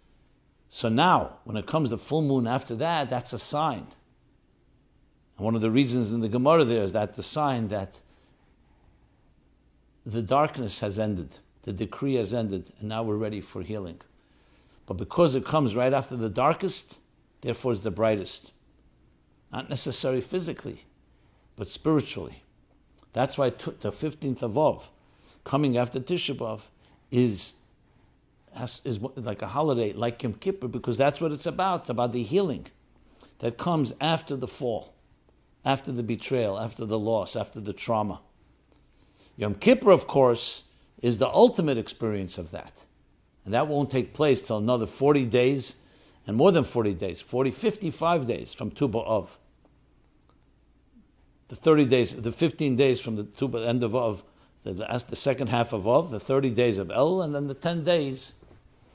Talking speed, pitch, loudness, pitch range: 165 wpm, 125 Hz, -26 LUFS, 110-140 Hz